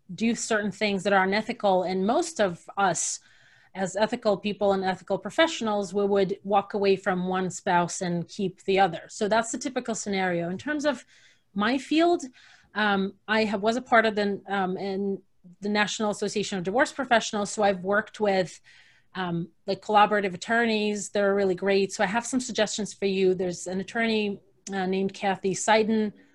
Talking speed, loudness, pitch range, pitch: 180 wpm, -26 LUFS, 190-220 Hz, 200 Hz